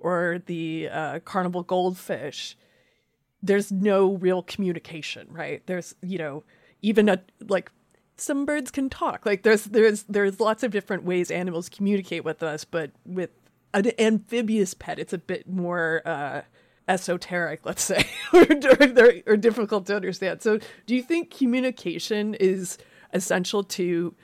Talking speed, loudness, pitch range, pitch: 145 wpm, -24 LUFS, 175-220 Hz, 190 Hz